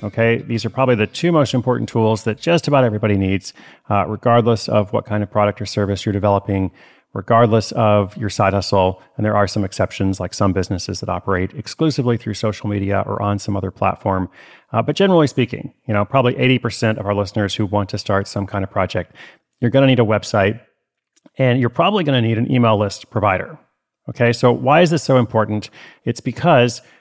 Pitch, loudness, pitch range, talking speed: 110 Hz, -18 LUFS, 100-125 Hz, 205 wpm